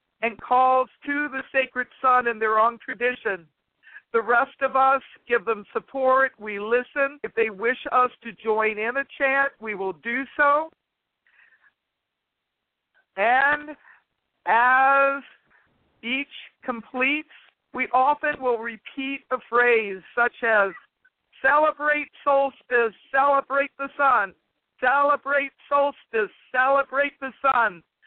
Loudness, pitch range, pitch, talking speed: -23 LUFS, 235-280 Hz, 260 Hz, 115 wpm